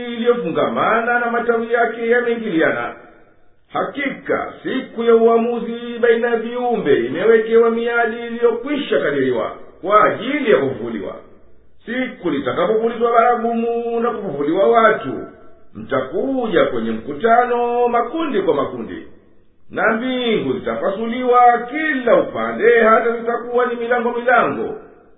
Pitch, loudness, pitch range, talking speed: 235 Hz, -17 LUFS, 230-245 Hz, 100 wpm